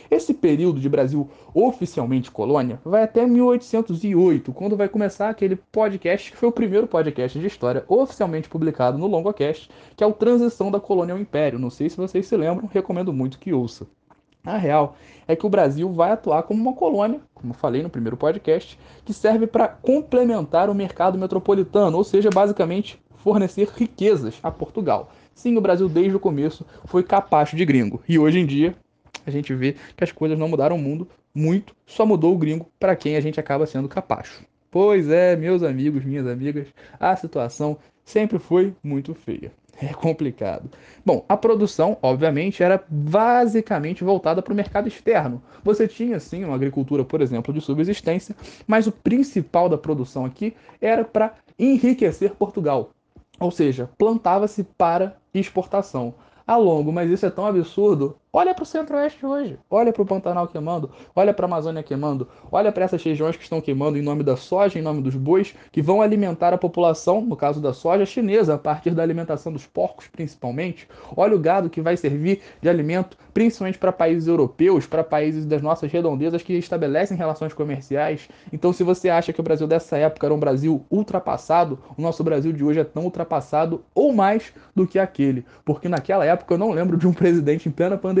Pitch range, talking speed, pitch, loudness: 150-200 Hz, 185 wpm, 175 Hz, -21 LUFS